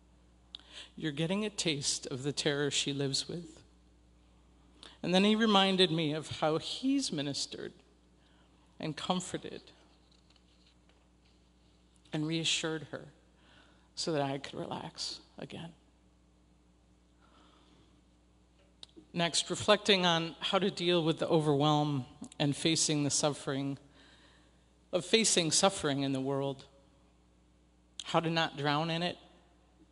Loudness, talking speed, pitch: -31 LUFS, 110 wpm, 140 Hz